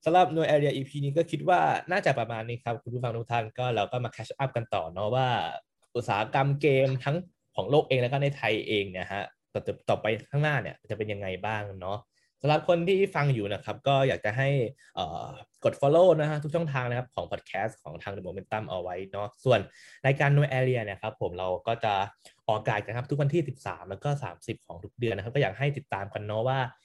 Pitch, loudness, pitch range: 125 Hz, -28 LUFS, 105-140 Hz